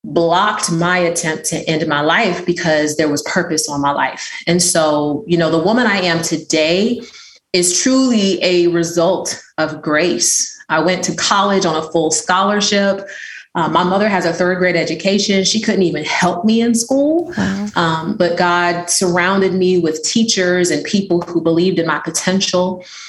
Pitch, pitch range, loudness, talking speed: 175 Hz, 165-195 Hz, -15 LUFS, 170 wpm